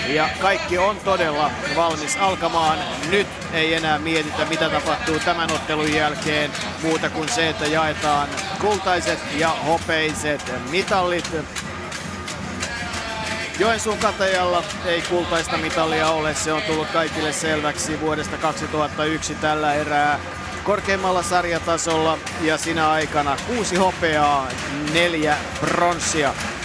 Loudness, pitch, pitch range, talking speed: -21 LUFS, 160 Hz, 150-175 Hz, 110 wpm